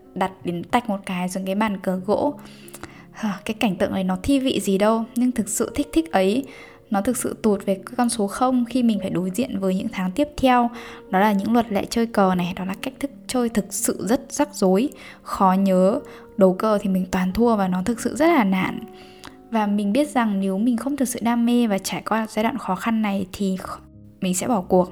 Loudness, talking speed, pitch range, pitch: -22 LUFS, 240 wpm, 190-240 Hz, 215 Hz